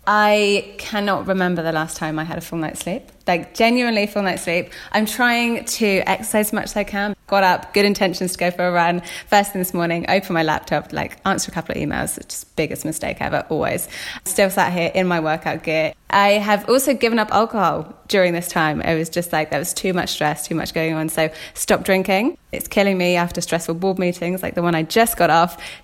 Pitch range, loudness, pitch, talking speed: 170-205 Hz, -19 LUFS, 180 Hz, 230 wpm